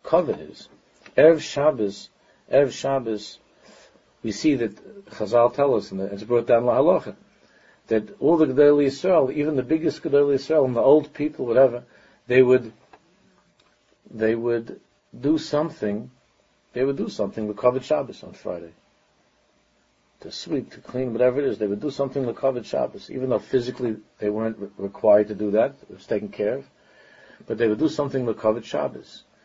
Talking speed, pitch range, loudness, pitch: 175 wpm, 110-145 Hz, -23 LUFS, 125 Hz